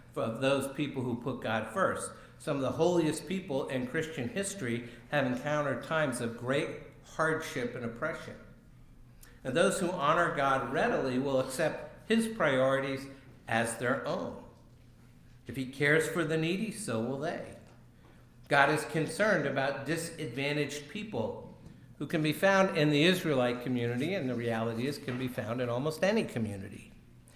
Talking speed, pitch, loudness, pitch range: 155 wpm, 135 Hz, -31 LUFS, 120-160 Hz